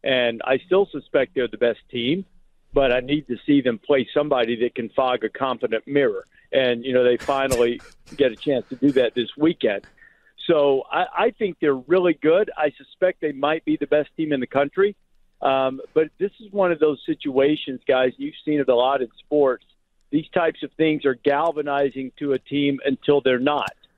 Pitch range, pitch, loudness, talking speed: 130-155 Hz, 145 Hz, -22 LUFS, 205 wpm